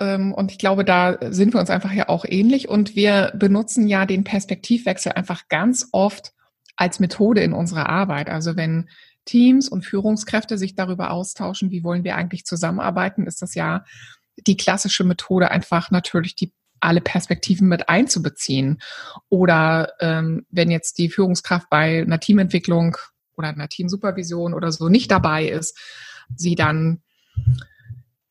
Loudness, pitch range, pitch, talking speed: -19 LUFS, 165-195 Hz, 185 Hz, 150 wpm